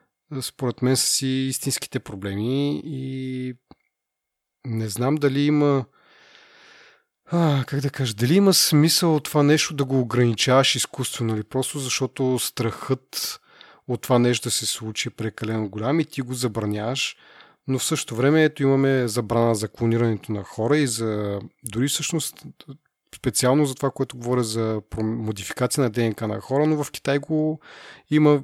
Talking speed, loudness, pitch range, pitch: 155 wpm, -23 LUFS, 115-145 Hz, 130 Hz